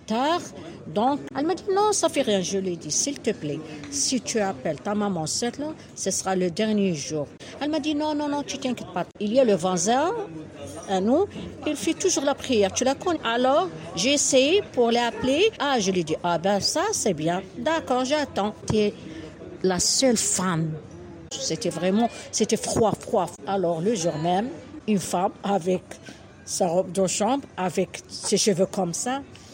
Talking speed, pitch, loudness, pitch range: 185 wpm, 210 Hz, -24 LUFS, 180-275 Hz